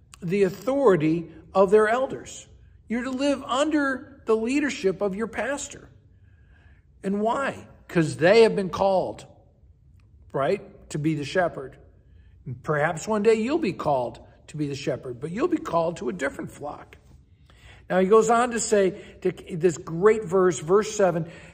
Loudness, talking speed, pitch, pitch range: -24 LUFS, 160 wpm, 190 Hz, 160-225 Hz